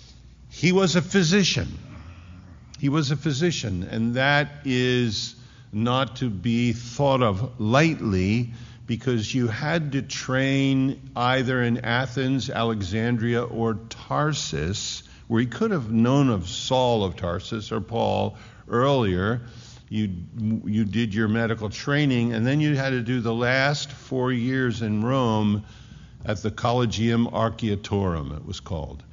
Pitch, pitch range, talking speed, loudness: 120 Hz, 110-130 Hz, 135 wpm, -24 LUFS